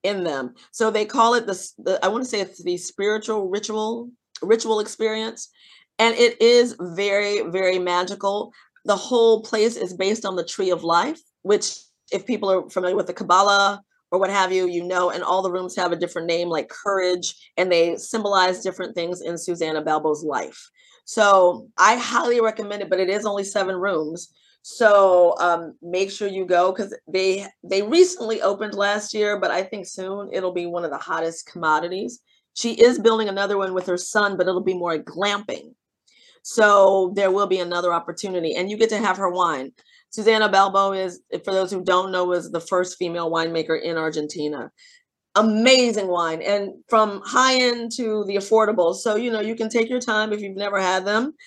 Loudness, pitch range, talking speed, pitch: -21 LUFS, 180-220 Hz, 190 wpm, 195 Hz